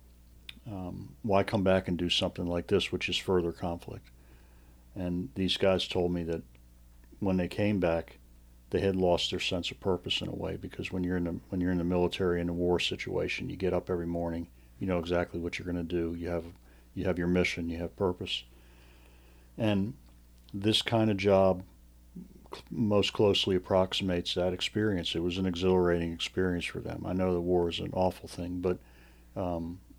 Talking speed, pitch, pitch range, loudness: 195 wpm, 90 Hz, 80-95 Hz, -31 LUFS